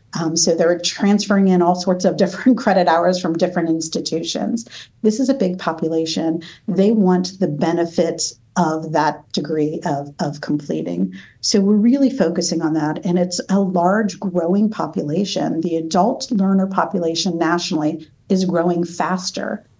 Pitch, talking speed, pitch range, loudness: 175 Hz, 150 wpm, 160-195 Hz, -18 LUFS